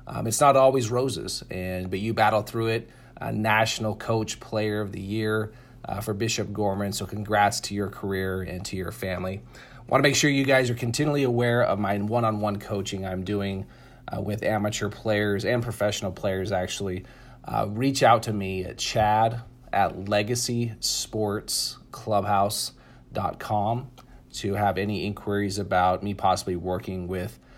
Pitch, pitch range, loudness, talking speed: 105 Hz, 100-120 Hz, -26 LUFS, 155 wpm